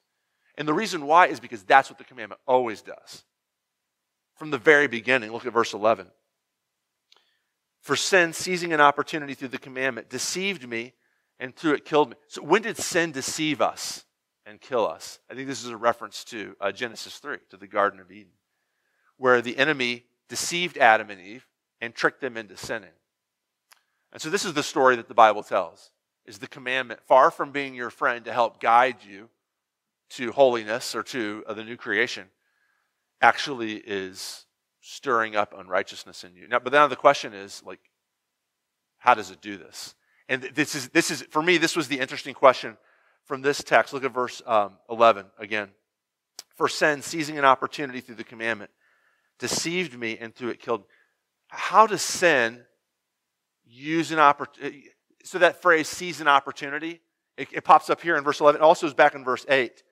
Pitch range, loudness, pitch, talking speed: 115-150 Hz, -23 LUFS, 130 Hz, 180 wpm